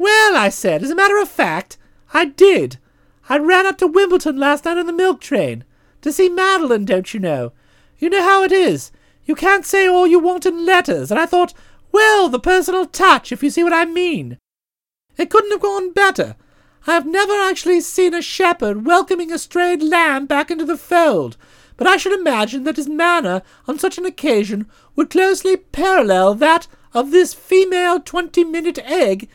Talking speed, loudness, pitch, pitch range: 190 wpm, -15 LUFS, 350 Hz, 300-375 Hz